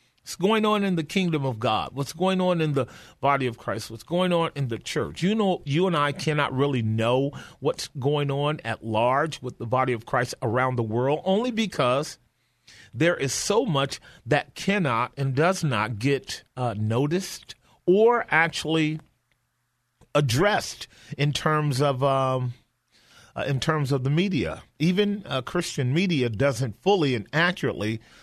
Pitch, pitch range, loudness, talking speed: 140 Hz, 125-170 Hz, -25 LUFS, 165 wpm